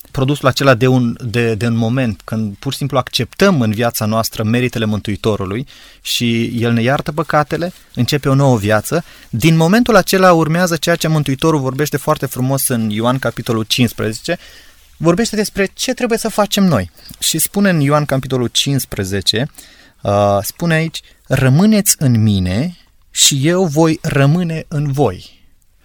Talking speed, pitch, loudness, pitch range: 155 wpm, 135 Hz, -15 LUFS, 115-165 Hz